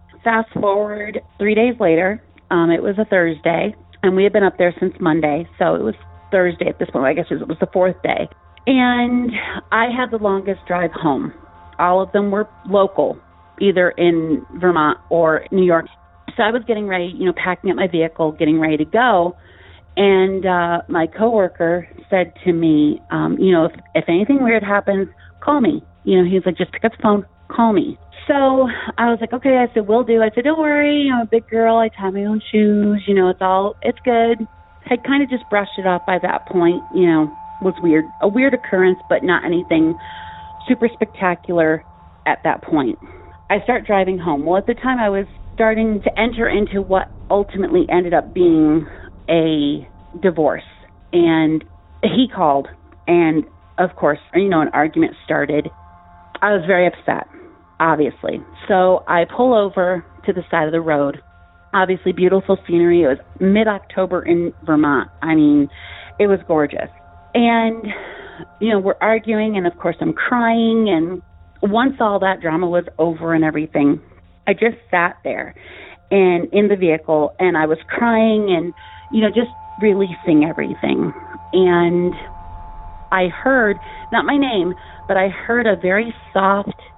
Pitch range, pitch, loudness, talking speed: 165-220 Hz, 185 Hz, -17 LUFS, 175 wpm